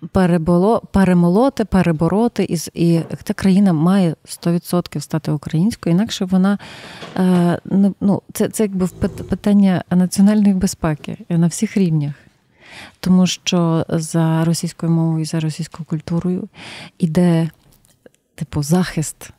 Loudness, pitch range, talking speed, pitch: -17 LUFS, 165-195 Hz, 110 wpm, 175 Hz